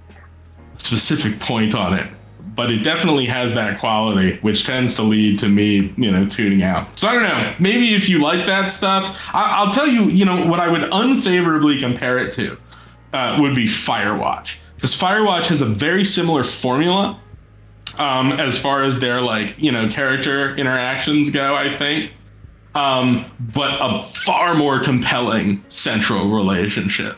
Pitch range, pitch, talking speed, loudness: 105-155 Hz, 130 Hz, 165 wpm, -17 LUFS